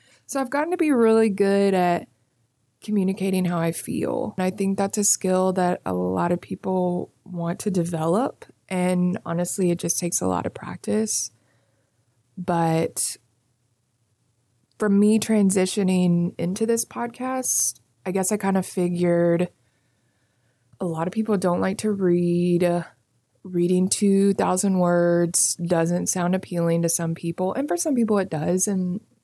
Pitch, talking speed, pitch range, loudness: 175 Hz, 150 wpm, 135-195 Hz, -22 LUFS